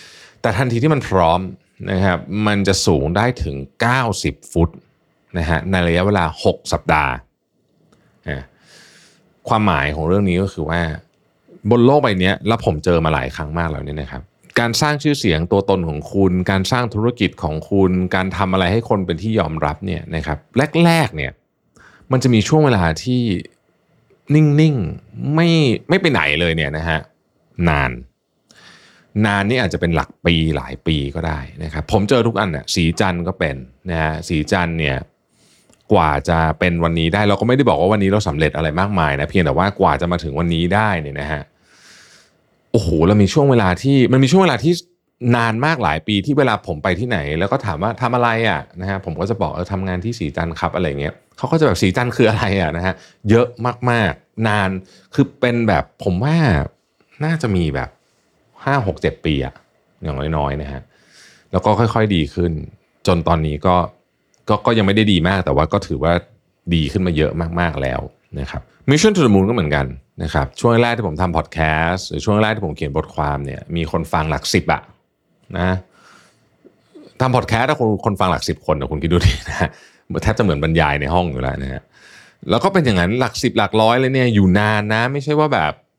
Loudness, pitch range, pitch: -17 LUFS, 80-115 Hz, 95 Hz